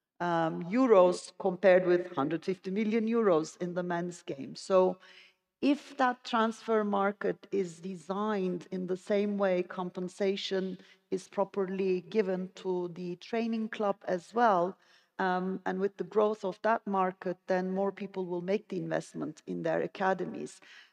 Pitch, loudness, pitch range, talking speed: 190 Hz, -31 LUFS, 180-205 Hz, 145 wpm